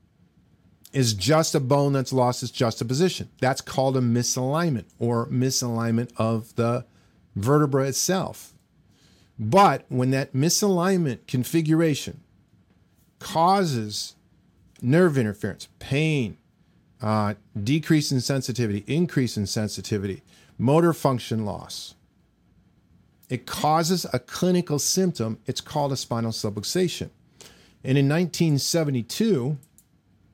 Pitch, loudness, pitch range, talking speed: 130 Hz, -24 LUFS, 110-150 Hz, 105 wpm